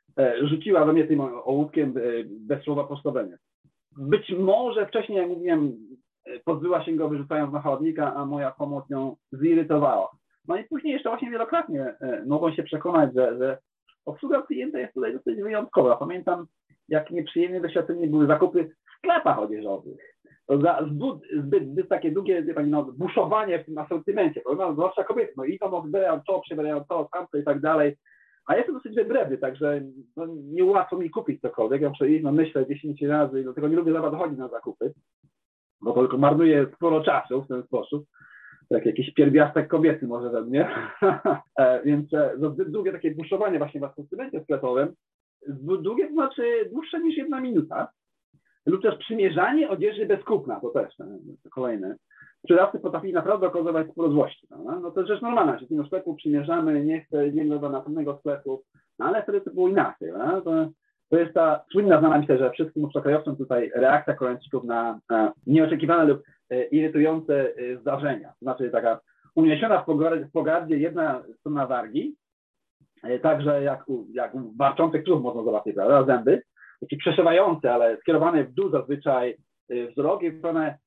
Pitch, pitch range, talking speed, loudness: 155 Hz, 145-195 Hz, 160 wpm, -24 LUFS